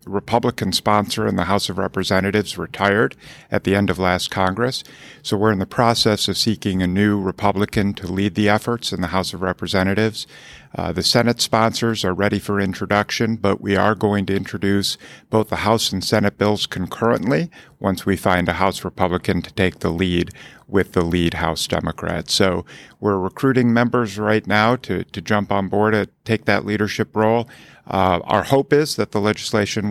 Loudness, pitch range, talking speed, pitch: -19 LUFS, 95-110 Hz, 185 wpm, 100 Hz